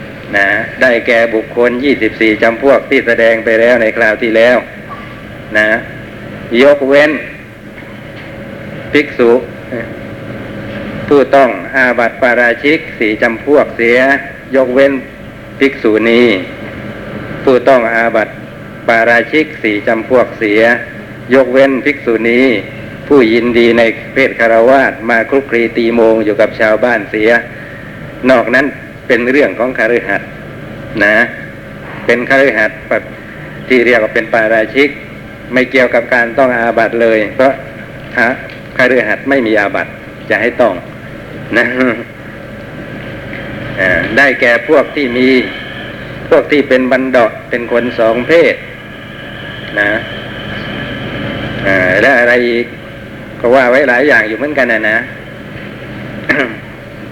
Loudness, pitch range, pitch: -10 LUFS, 110-135 Hz, 120 Hz